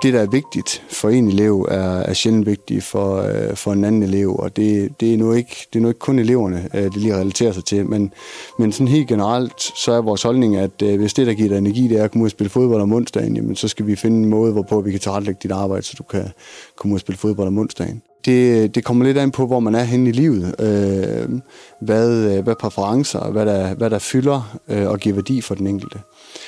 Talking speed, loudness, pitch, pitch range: 240 wpm, -18 LUFS, 110 Hz, 100-120 Hz